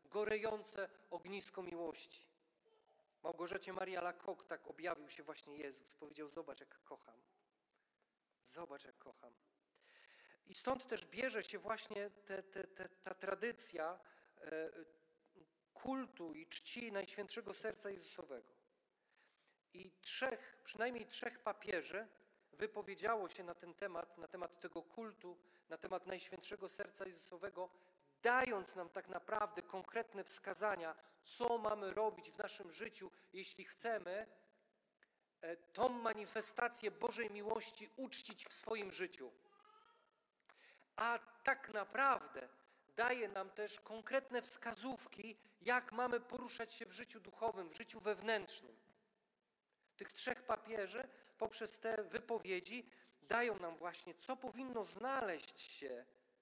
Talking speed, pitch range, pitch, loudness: 115 wpm, 185-235 Hz, 210 Hz, -45 LUFS